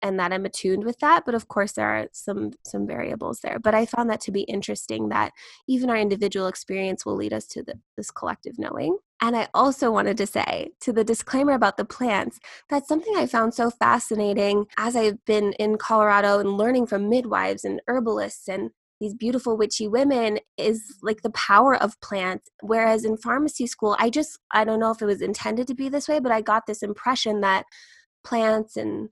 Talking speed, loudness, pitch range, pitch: 205 wpm, -23 LUFS, 200-245 Hz, 220 Hz